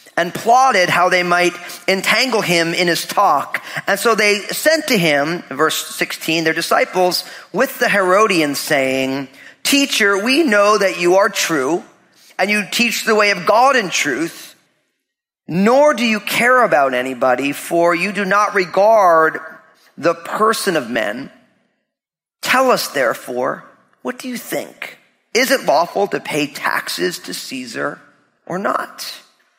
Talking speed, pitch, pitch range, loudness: 145 wpm, 190 Hz, 165-225 Hz, -15 LUFS